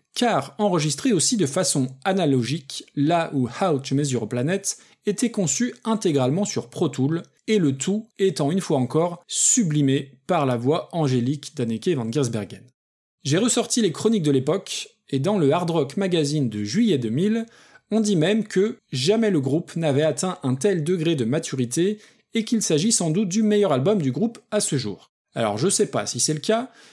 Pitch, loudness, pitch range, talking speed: 170 Hz, -22 LUFS, 140-210 Hz, 185 wpm